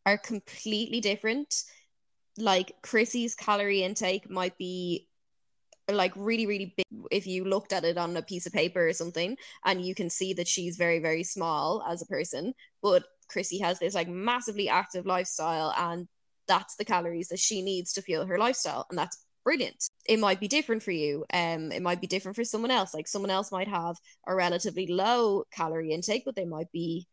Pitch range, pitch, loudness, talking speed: 175-210 Hz, 185 Hz, -30 LUFS, 190 wpm